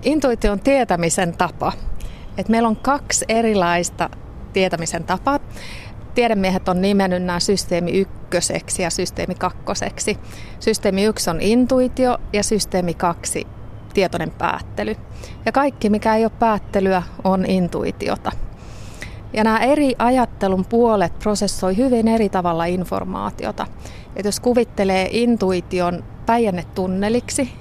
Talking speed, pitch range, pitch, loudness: 115 wpm, 175-225 Hz, 190 Hz, -19 LUFS